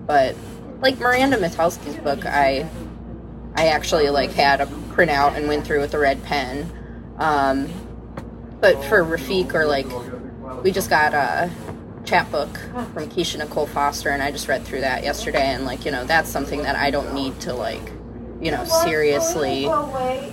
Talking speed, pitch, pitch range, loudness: 170 wpm, 150 Hz, 140-180 Hz, -21 LUFS